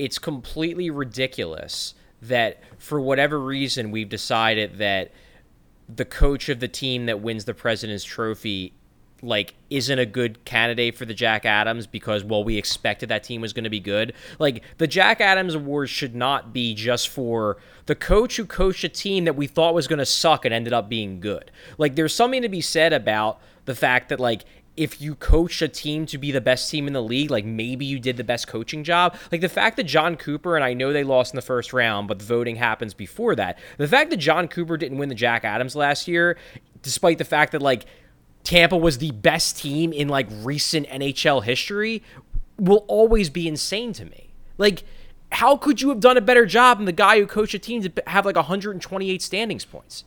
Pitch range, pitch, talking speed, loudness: 115-170 Hz, 140 Hz, 210 wpm, -21 LUFS